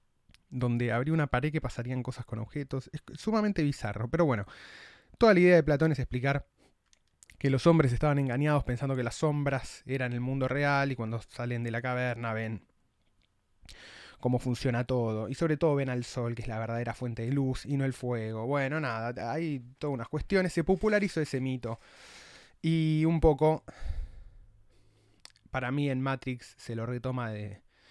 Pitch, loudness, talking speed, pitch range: 130 Hz, -30 LUFS, 175 wpm, 120-150 Hz